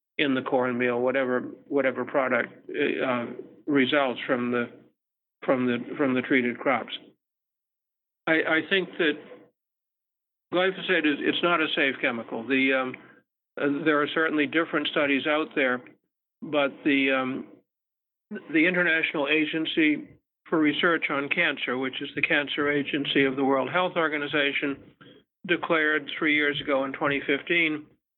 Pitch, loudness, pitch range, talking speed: 145 Hz, -25 LUFS, 135-160 Hz, 130 wpm